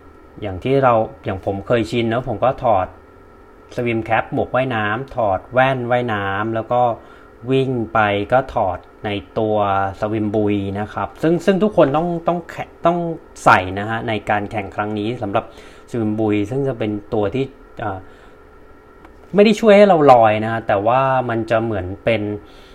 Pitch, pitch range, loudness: 115 Hz, 105-135 Hz, -18 LUFS